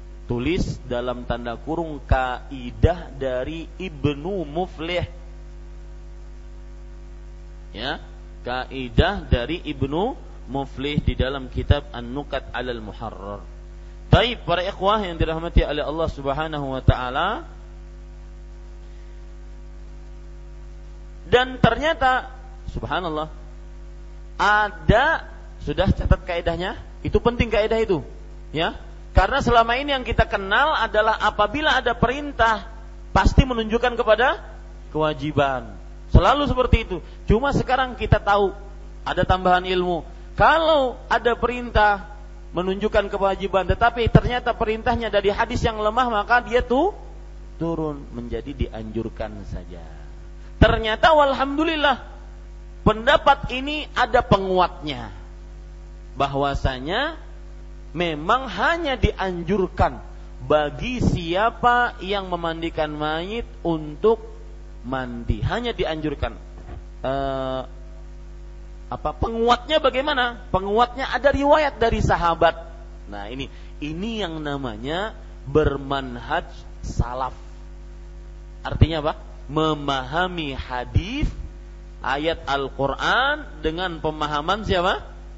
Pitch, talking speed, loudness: 160 Hz, 90 wpm, -22 LUFS